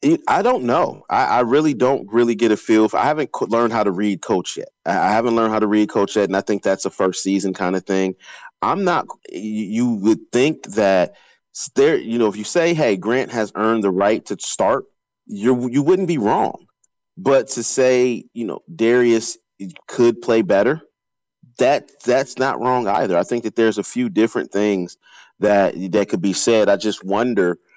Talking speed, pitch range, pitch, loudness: 200 wpm, 100-125 Hz, 110 Hz, -18 LUFS